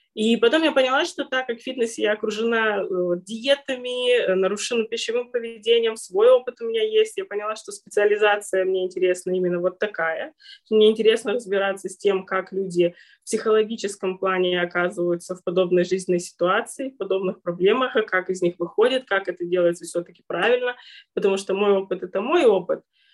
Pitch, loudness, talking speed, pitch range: 205 Hz, -22 LUFS, 160 wpm, 185-235 Hz